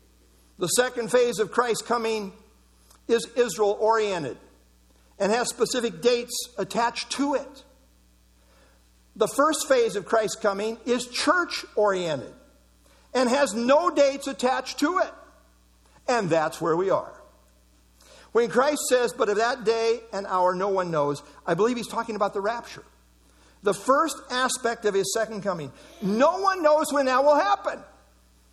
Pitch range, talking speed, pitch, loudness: 170-250 Hz, 145 wpm, 225 Hz, -24 LUFS